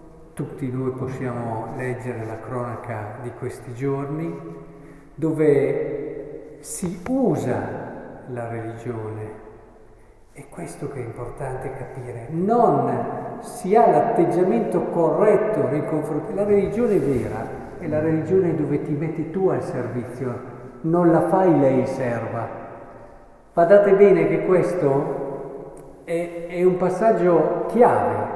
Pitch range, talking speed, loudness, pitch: 120-175 Hz, 115 wpm, -21 LUFS, 140 Hz